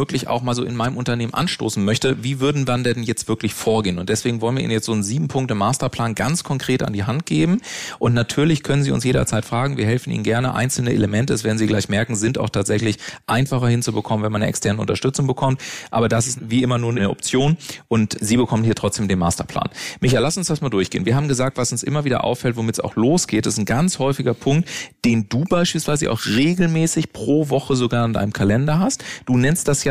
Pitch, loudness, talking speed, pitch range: 120 Hz, -20 LUFS, 230 wpm, 110-140 Hz